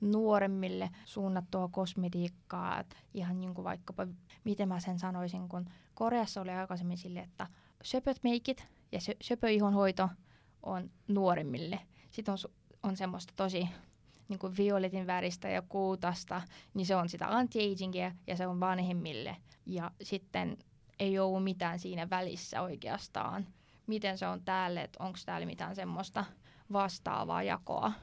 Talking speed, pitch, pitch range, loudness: 135 wpm, 185 Hz, 180-200 Hz, -36 LUFS